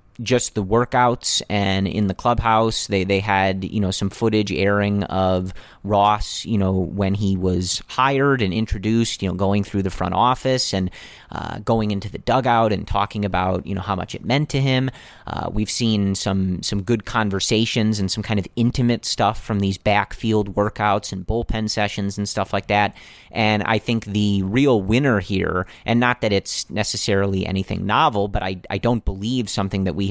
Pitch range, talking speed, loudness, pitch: 95-115 Hz, 190 wpm, -20 LUFS, 105 Hz